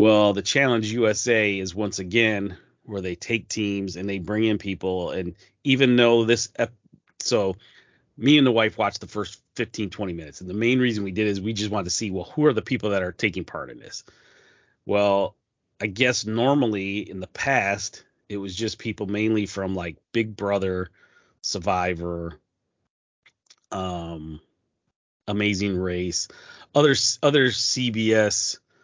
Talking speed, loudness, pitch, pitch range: 165 wpm, -23 LUFS, 105 Hz, 95-115 Hz